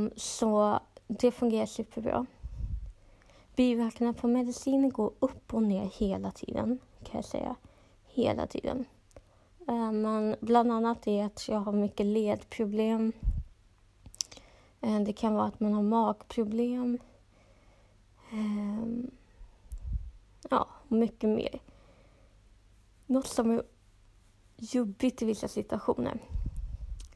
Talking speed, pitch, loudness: 95 wpm, 215 Hz, -31 LUFS